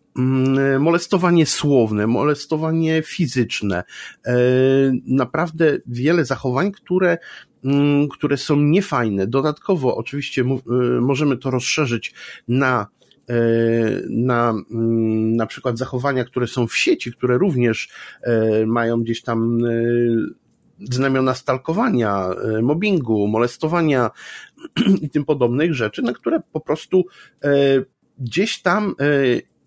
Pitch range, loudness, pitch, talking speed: 120-155 Hz, -19 LUFS, 130 Hz, 90 wpm